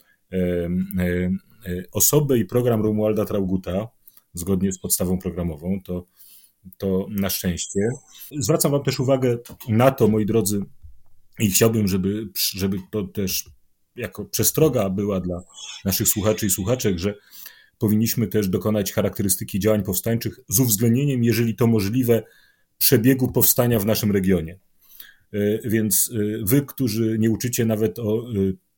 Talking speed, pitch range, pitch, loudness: 125 wpm, 95-115 Hz, 105 Hz, -21 LUFS